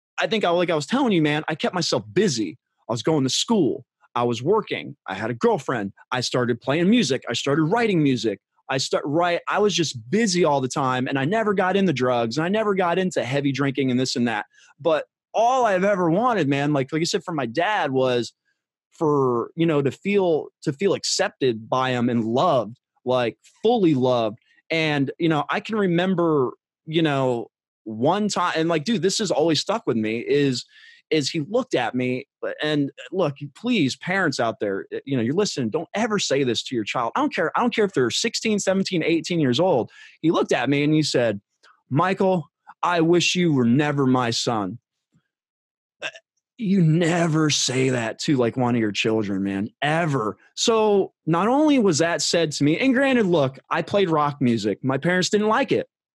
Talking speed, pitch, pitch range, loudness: 205 wpm, 155 Hz, 130-190 Hz, -22 LUFS